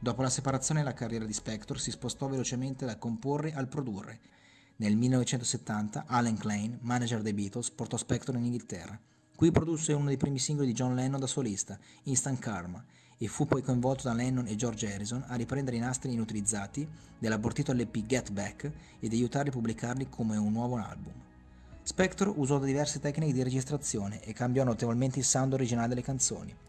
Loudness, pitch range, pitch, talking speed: -32 LUFS, 110-135 Hz, 125 Hz, 175 wpm